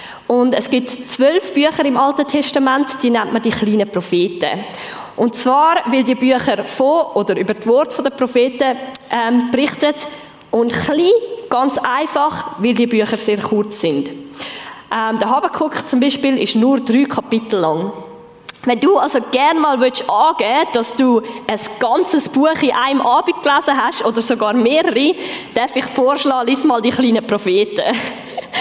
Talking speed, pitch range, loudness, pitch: 155 wpm, 230-290 Hz, -15 LUFS, 255 Hz